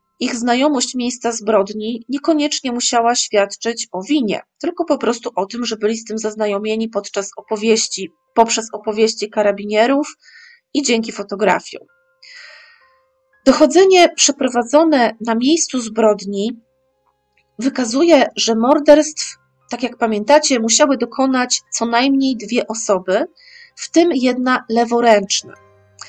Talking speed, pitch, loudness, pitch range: 110 wpm, 235 Hz, -16 LUFS, 215-285 Hz